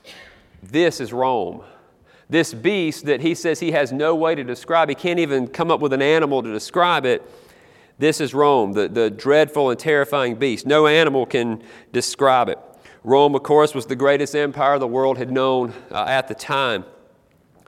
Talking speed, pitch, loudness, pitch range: 185 wpm, 145 Hz, -19 LUFS, 130-155 Hz